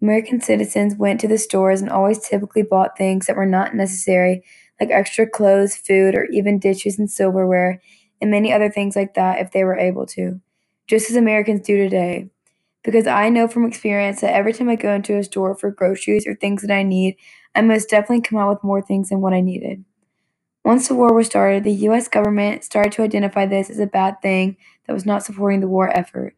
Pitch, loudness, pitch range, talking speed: 200 Hz, -18 LUFS, 190-210 Hz, 215 wpm